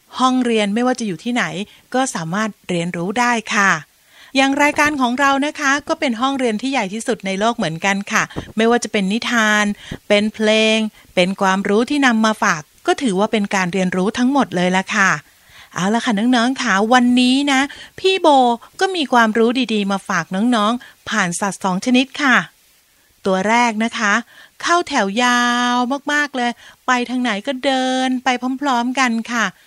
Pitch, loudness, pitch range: 235 Hz, -17 LUFS, 205-255 Hz